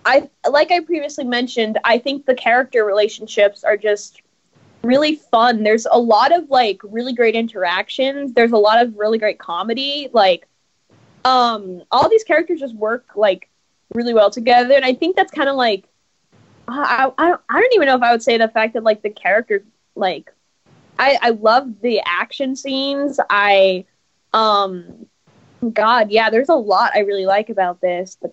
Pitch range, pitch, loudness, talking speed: 210-275 Hz, 235 Hz, -16 LUFS, 175 wpm